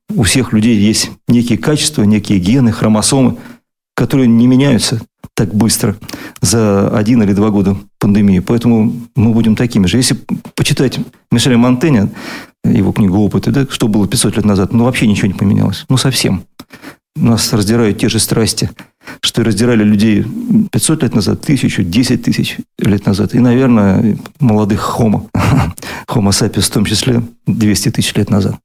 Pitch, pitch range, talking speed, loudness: 115 Hz, 105-120 Hz, 160 wpm, -12 LUFS